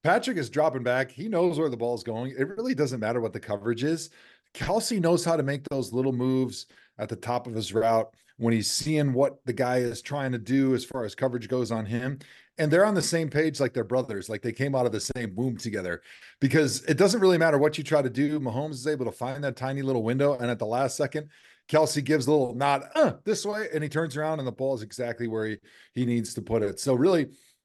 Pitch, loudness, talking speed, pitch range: 135 Hz, -27 LUFS, 255 wpm, 120-155 Hz